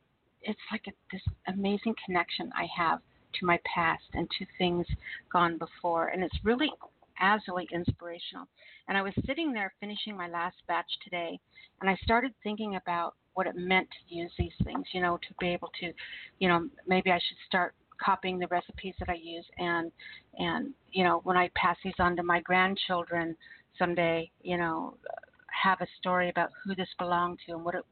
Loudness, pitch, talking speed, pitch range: -31 LUFS, 180 Hz, 185 wpm, 170-195 Hz